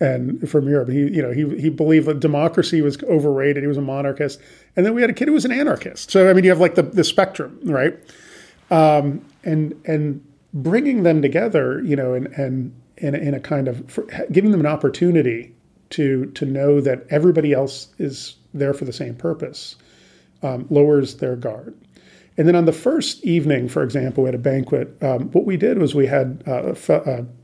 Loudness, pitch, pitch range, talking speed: -19 LUFS, 145 Hz, 135-165 Hz, 205 wpm